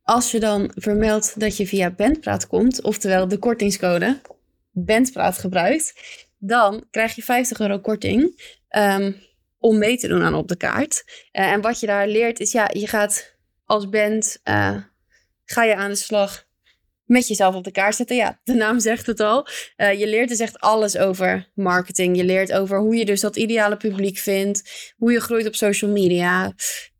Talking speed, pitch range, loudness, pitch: 185 wpm, 200-230 Hz, -20 LUFS, 215 Hz